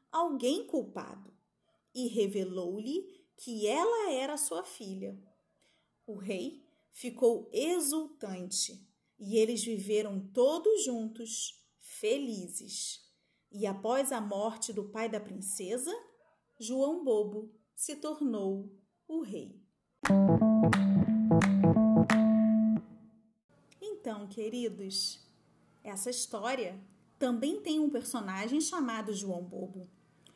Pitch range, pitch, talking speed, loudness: 200-265 Hz, 220 Hz, 85 wpm, -32 LUFS